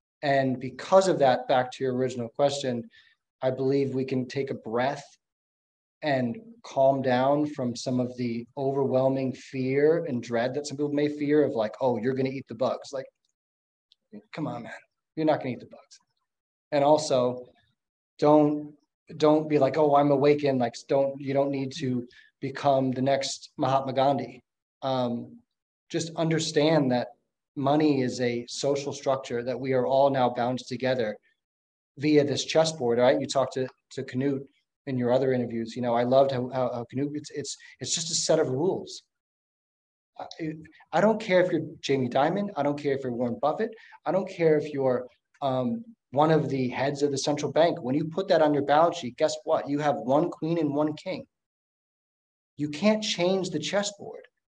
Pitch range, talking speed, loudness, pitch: 125-150 Hz, 185 wpm, -26 LUFS, 135 Hz